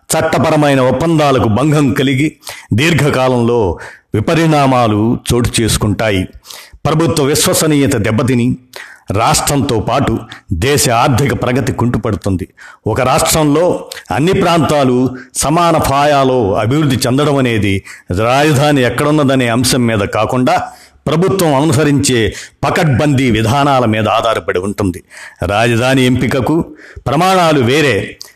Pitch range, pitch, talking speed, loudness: 115-150 Hz, 130 Hz, 90 wpm, -12 LUFS